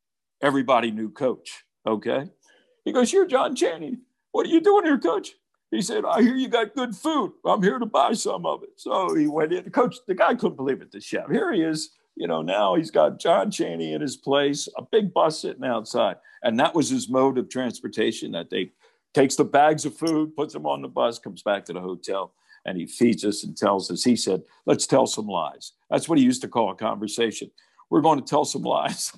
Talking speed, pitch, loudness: 230 wpm, 160 Hz, -24 LUFS